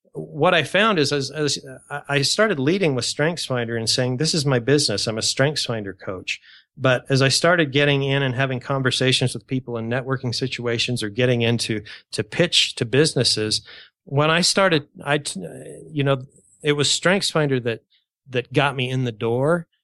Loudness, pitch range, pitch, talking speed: -20 LUFS, 125-150 Hz, 135 Hz, 175 wpm